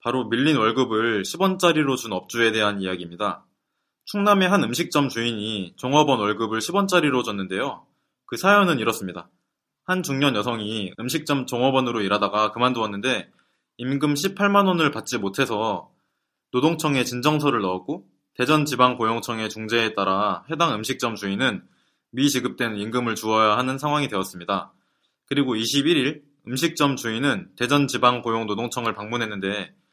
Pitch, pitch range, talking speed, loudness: 125 Hz, 110-145 Hz, 335 characters per minute, -22 LUFS